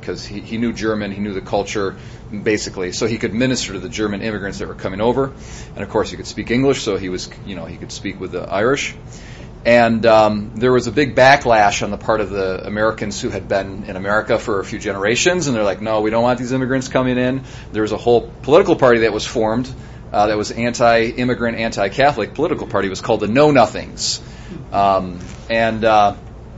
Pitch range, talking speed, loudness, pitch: 105-120 Hz, 220 wpm, -17 LUFS, 110 Hz